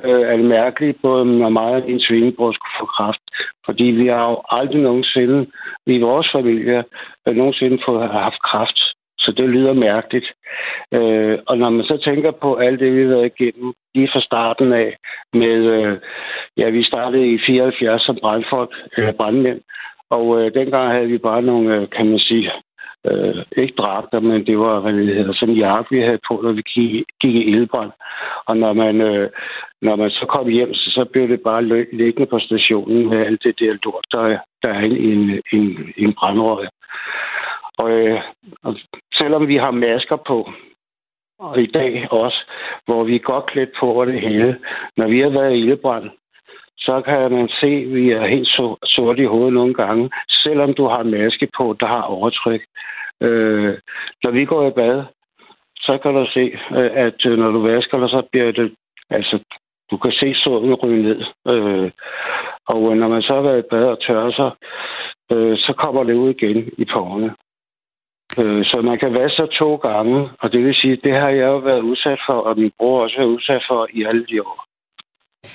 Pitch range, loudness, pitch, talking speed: 110-130 Hz, -16 LUFS, 120 Hz, 195 wpm